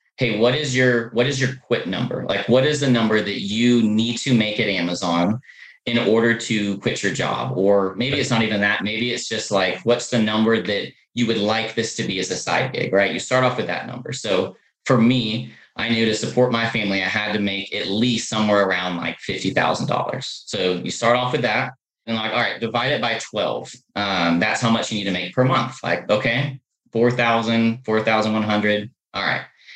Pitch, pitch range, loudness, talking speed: 115 Hz, 105-120 Hz, -20 LUFS, 215 wpm